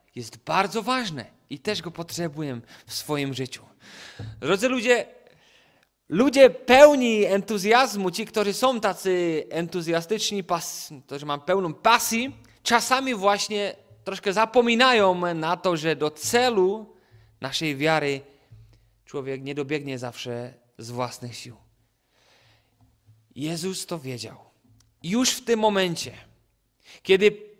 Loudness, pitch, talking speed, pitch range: -23 LUFS, 165 Hz, 110 wpm, 125-210 Hz